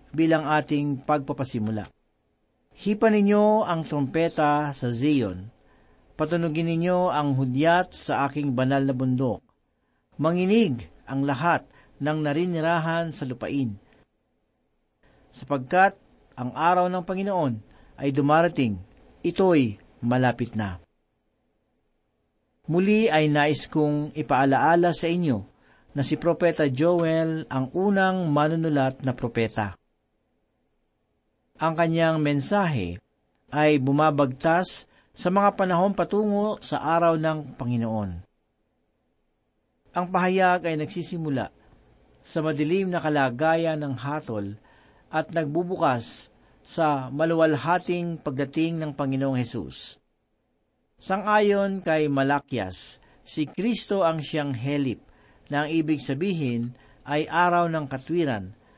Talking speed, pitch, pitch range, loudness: 100 wpm, 150 Hz, 130-170 Hz, -24 LUFS